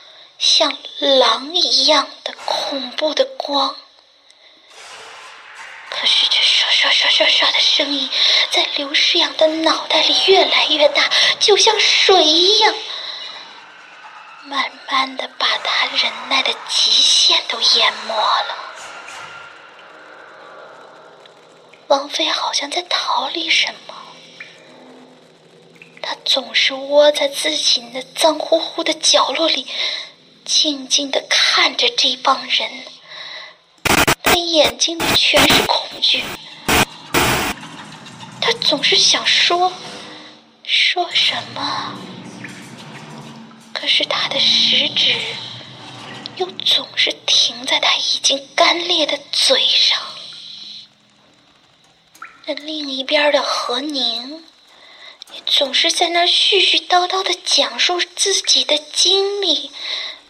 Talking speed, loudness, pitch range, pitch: 140 characters per minute, -14 LUFS, 285-355 Hz, 310 Hz